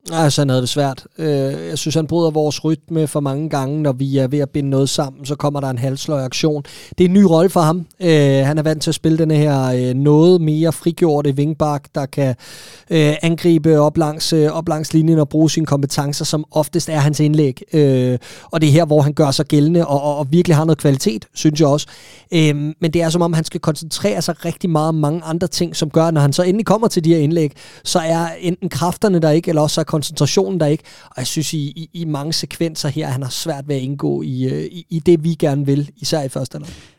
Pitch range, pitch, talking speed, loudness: 145-165 Hz, 155 Hz, 255 wpm, -16 LUFS